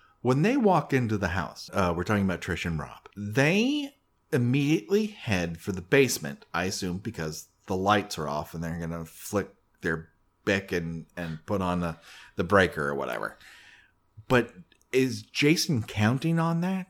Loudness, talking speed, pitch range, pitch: -28 LUFS, 170 wpm, 85-135 Hz, 100 Hz